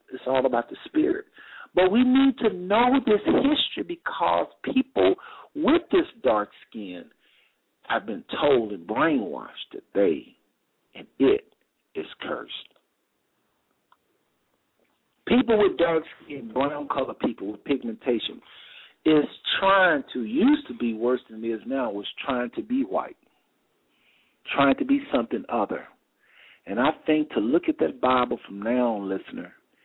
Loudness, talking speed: -24 LUFS, 145 wpm